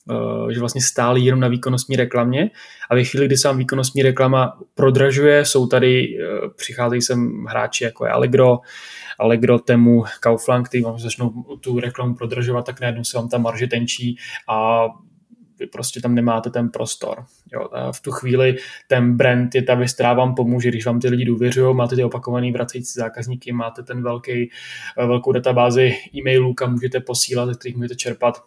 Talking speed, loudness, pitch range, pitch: 175 wpm, -18 LUFS, 120-130 Hz, 125 Hz